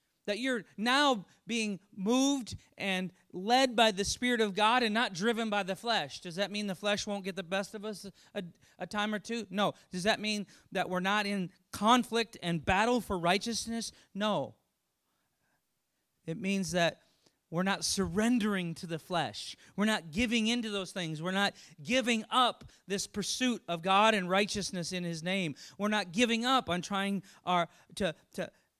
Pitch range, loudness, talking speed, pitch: 180-220 Hz, -31 LUFS, 175 wpm, 200 Hz